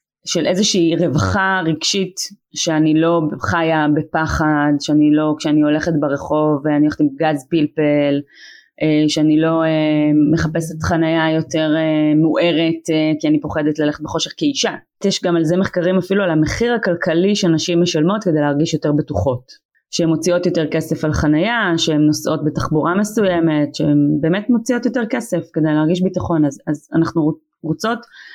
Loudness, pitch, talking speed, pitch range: -17 LUFS, 160 Hz, 140 wpm, 150-175 Hz